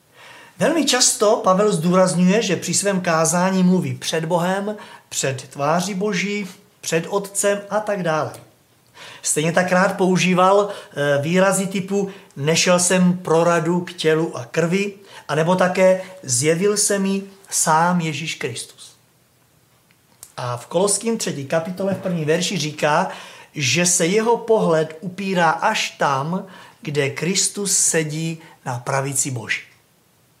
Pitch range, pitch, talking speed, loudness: 160-195 Hz, 180 Hz, 120 wpm, -19 LUFS